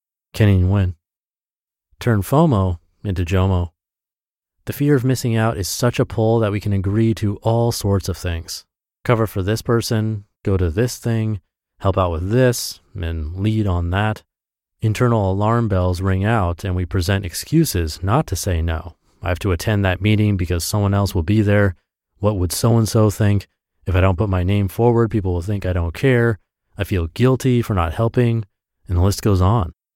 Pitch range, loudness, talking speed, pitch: 90-110 Hz, -19 LUFS, 190 wpm, 100 Hz